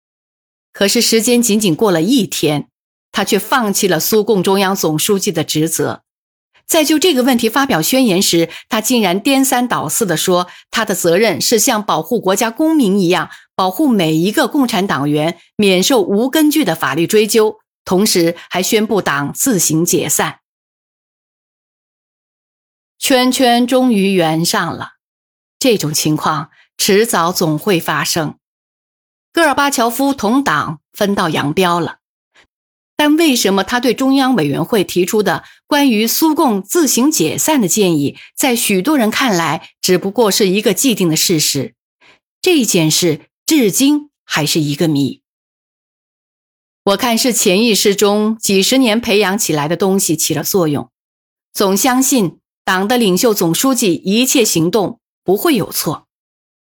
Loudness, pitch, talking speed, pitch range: -13 LUFS, 205 Hz, 220 characters per minute, 175-250 Hz